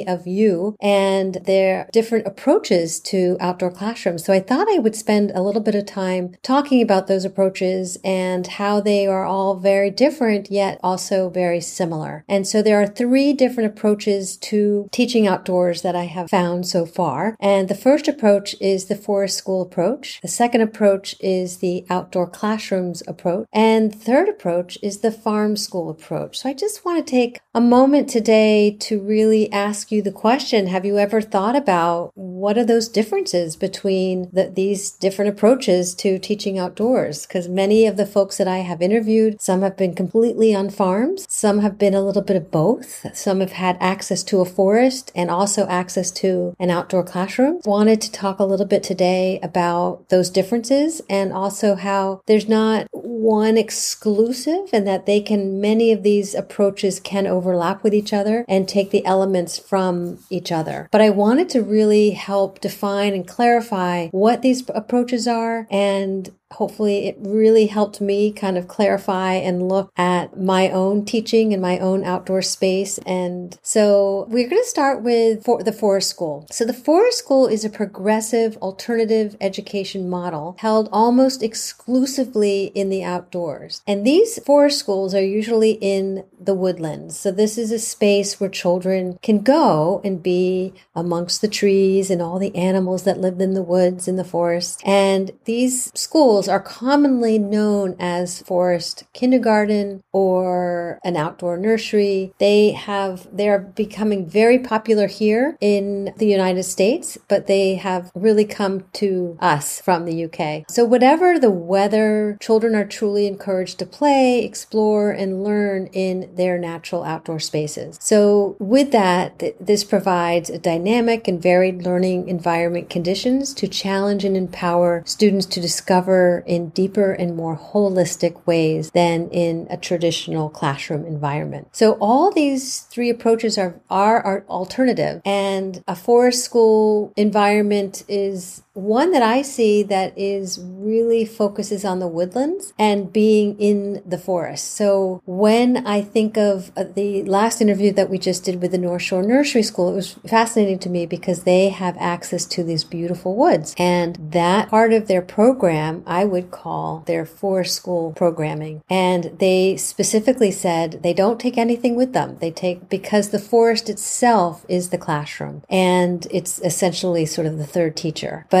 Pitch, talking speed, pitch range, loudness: 195 Hz, 165 wpm, 180-215 Hz, -19 LUFS